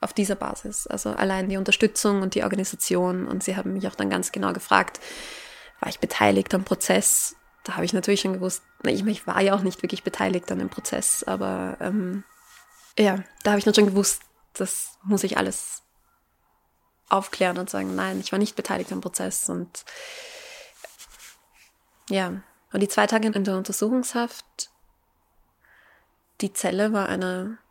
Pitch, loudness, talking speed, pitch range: 195 Hz, -24 LUFS, 170 wpm, 180-210 Hz